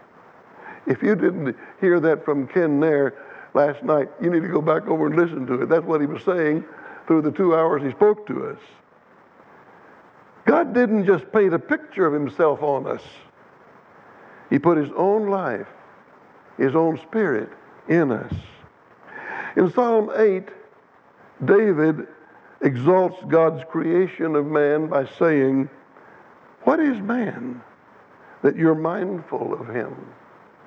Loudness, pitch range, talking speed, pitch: -21 LUFS, 150-195 Hz, 140 wpm, 165 Hz